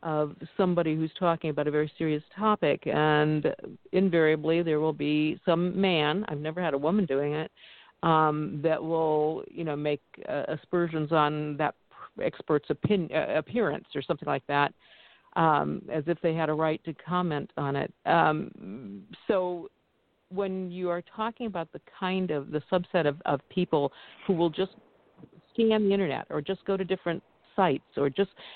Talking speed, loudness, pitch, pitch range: 165 wpm, -28 LUFS, 160 Hz, 150-185 Hz